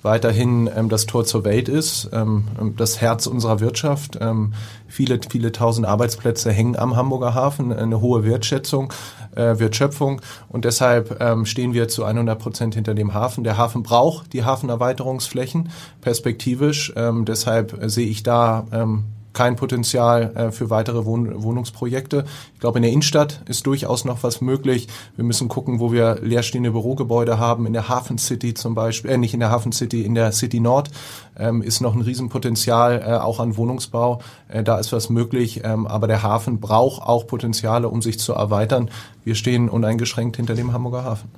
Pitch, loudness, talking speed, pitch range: 120 Hz, -20 LUFS, 170 wpm, 115-125 Hz